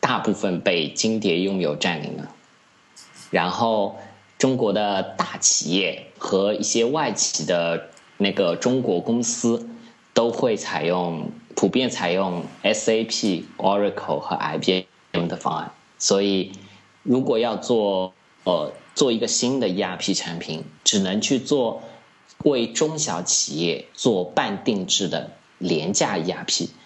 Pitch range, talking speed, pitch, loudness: 90-115 Hz, 205 characters per minute, 100 Hz, -22 LUFS